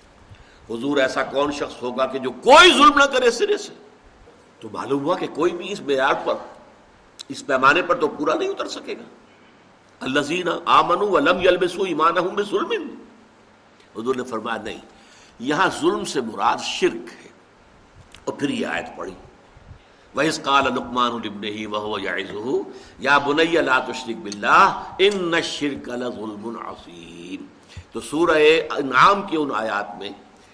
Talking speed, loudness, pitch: 135 wpm, -19 LUFS, 150 Hz